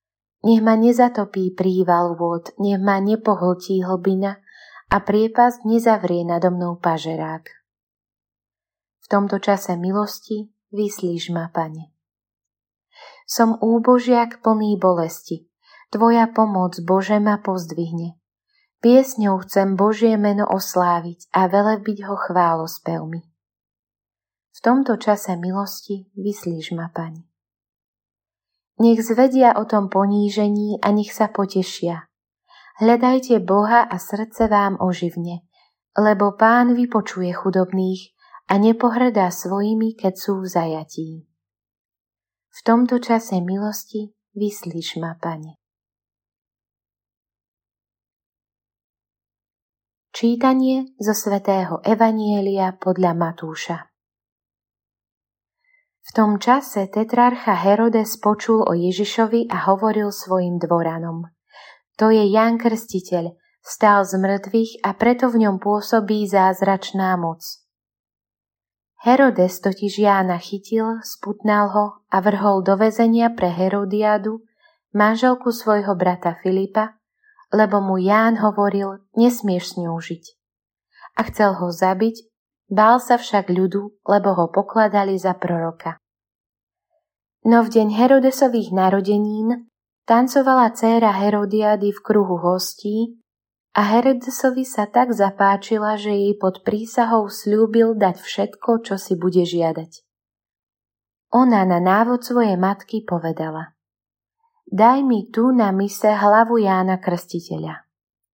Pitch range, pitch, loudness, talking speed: 170-220 Hz, 200 Hz, -19 LUFS, 105 wpm